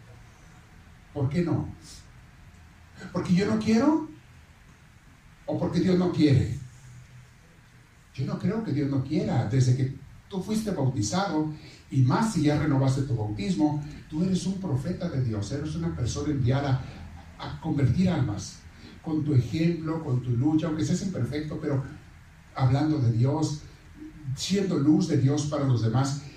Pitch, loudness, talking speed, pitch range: 145 Hz, -27 LUFS, 145 wpm, 125-160 Hz